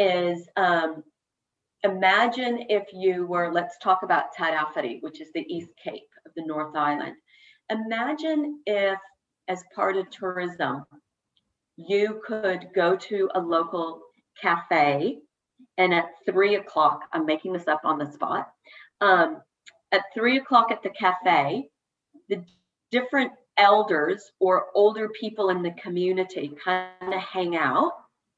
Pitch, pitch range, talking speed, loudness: 190 Hz, 175-215 Hz, 135 wpm, -25 LUFS